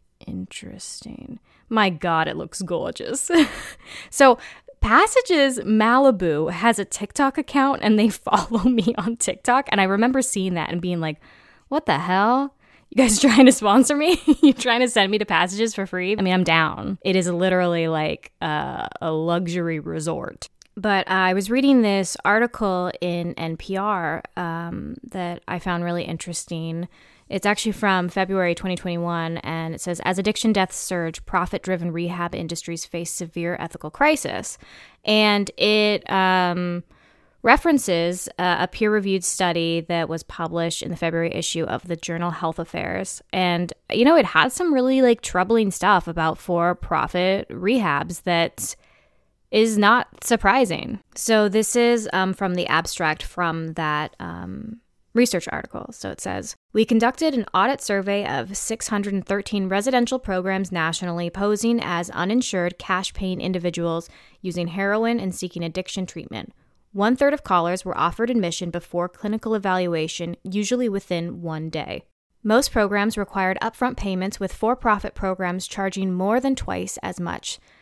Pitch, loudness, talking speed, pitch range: 190 Hz, -21 LUFS, 150 wpm, 175-225 Hz